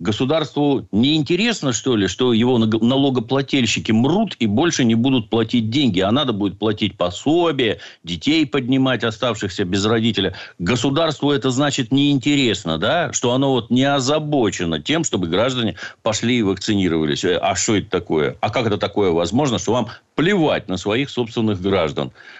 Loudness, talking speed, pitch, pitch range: -18 LUFS, 155 wpm, 120 Hz, 105-140 Hz